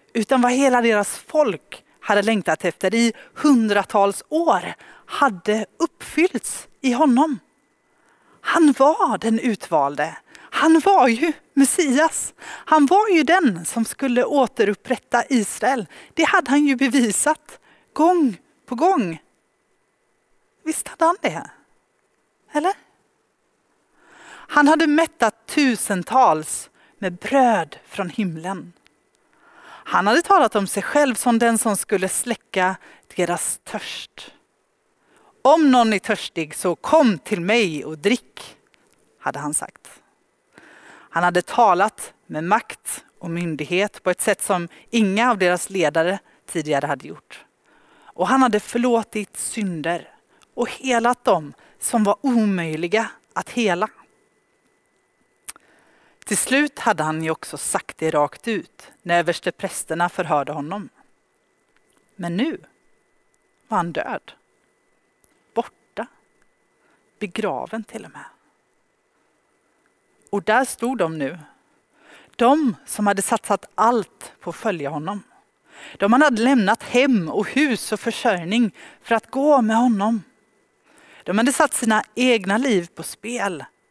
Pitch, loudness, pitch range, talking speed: 225 Hz, -20 LUFS, 195-270 Hz, 120 wpm